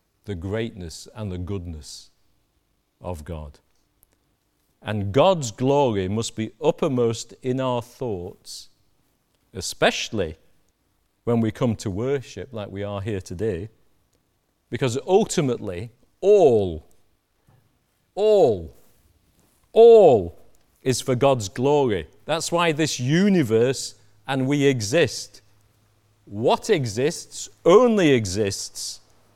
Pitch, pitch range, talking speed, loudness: 110 Hz, 100-130 Hz, 95 wpm, -21 LUFS